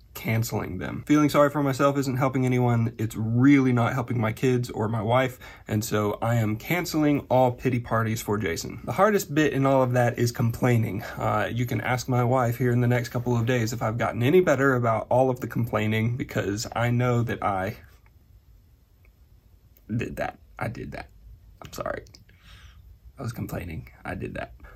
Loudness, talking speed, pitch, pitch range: -25 LUFS, 190 wpm, 120 Hz, 110-130 Hz